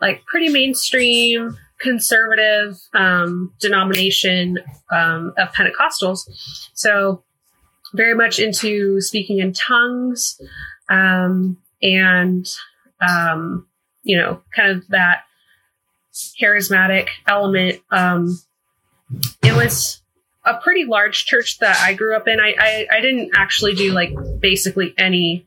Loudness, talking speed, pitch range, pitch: -16 LUFS, 110 wpm, 175-220 Hz, 190 Hz